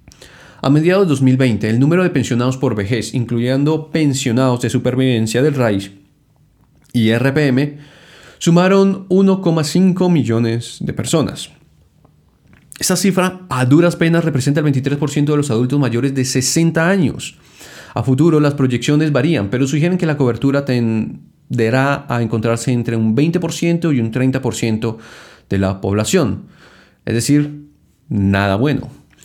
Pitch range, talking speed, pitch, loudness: 120-155 Hz, 130 wpm, 135 Hz, -16 LUFS